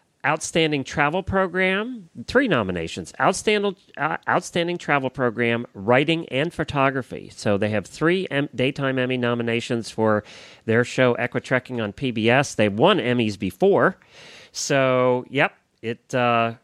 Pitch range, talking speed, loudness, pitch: 115-150 Hz, 125 wpm, -22 LUFS, 125 Hz